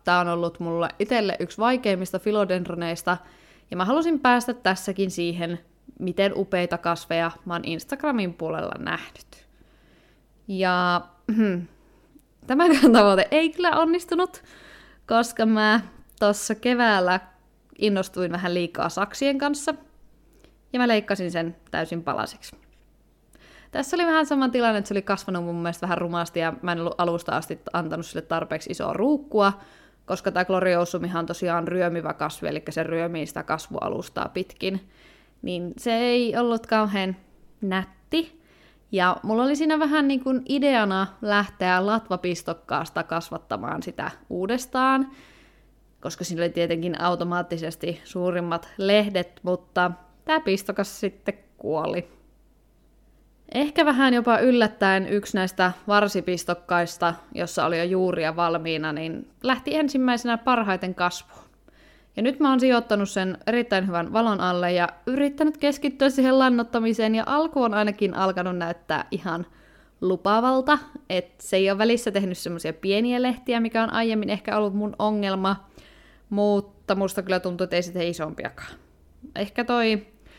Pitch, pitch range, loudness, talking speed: 195 Hz, 175-235 Hz, -24 LUFS, 130 wpm